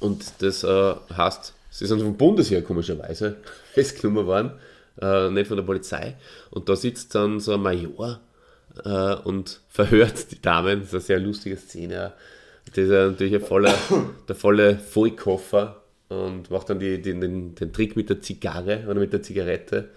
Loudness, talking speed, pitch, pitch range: -23 LUFS, 170 wpm, 100 Hz, 95-105 Hz